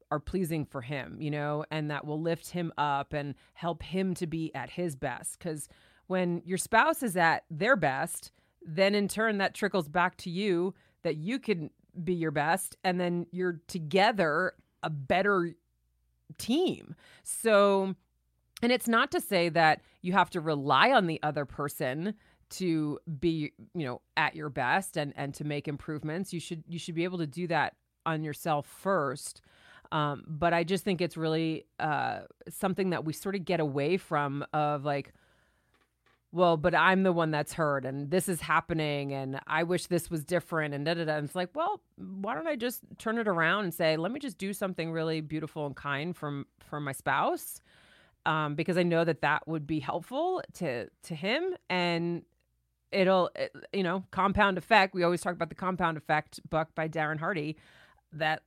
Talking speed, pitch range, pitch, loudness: 190 wpm, 150-185 Hz, 165 Hz, -30 LUFS